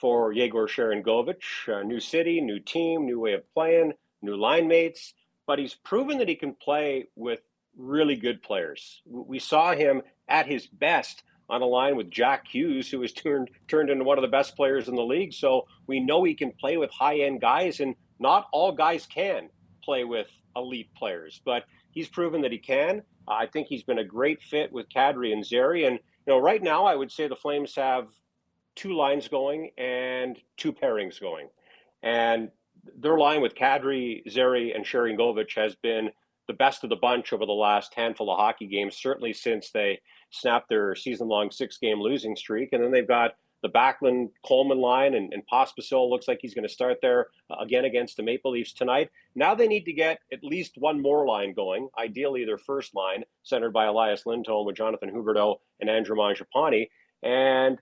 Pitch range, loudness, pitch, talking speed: 115-160 Hz, -26 LUFS, 130 Hz, 195 wpm